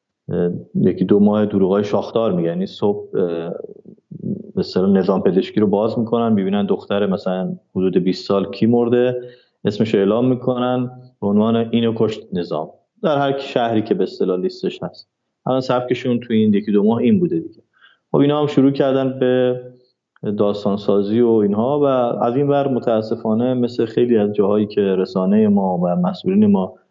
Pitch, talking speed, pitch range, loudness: 115 Hz, 165 wpm, 100-125 Hz, -18 LUFS